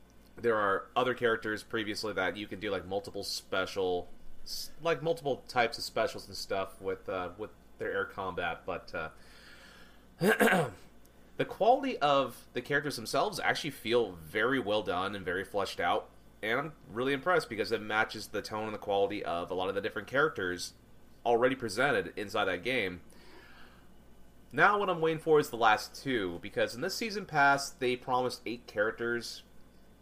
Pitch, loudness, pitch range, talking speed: 120 Hz, -32 LUFS, 105-155 Hz, 170 wpm